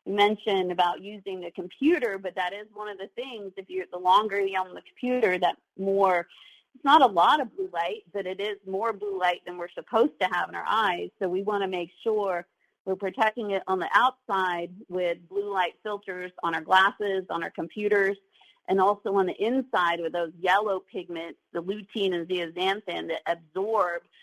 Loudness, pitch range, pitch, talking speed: -27 LUFS, 180-205 Hz, 190 Hz, 200 wpm